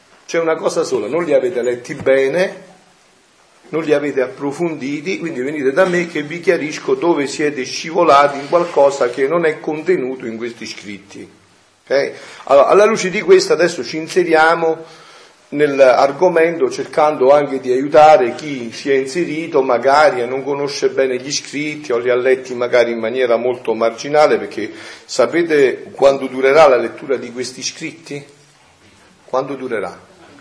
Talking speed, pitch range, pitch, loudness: 150 wpm, 130-170 Hz, 145 Hz, -15 LUFS